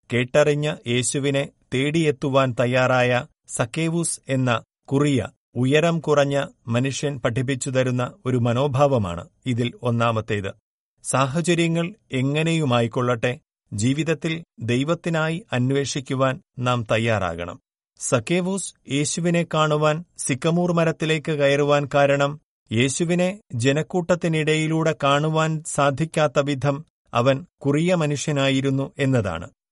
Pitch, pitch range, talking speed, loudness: 140 Hz, 125-155 Hz, 80 wpm, -22 LUFS